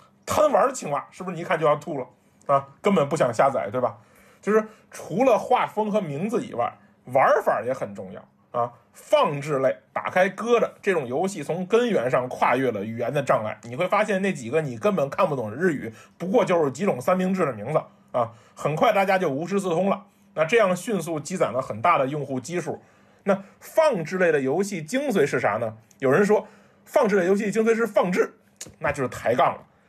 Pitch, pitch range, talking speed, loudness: 185 Hz, 140-210 Hz, 300 characters per minute, -24 LUFS